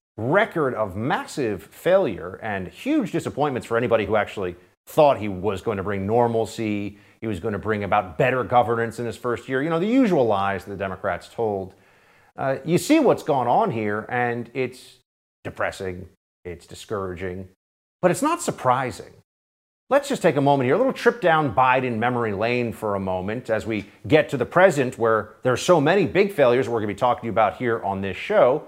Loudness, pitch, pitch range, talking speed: -22 LUFS, 115 Hz, 100-135 Hz, 200 wpm